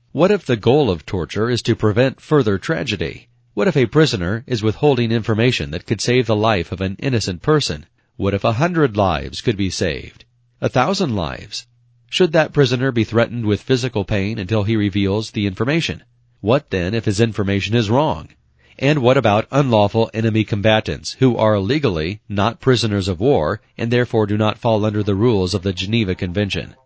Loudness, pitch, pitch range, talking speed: -18 LUFS, 110 Hz, 100-125 Hz, 185 wpm